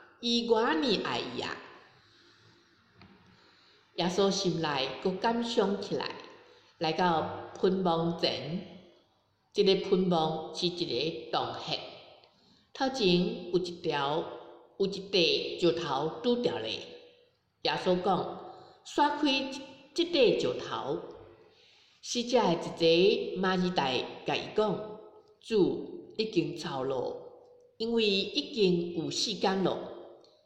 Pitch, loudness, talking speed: 200 Hz, -30 LUFS, 150 characters per minute